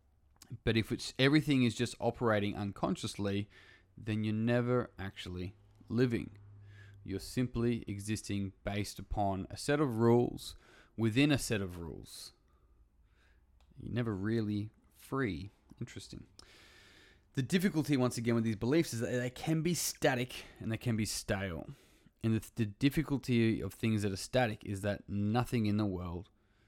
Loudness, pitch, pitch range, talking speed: -34 LUFS, 110 Hz, 100-125 Hz, 145 wpm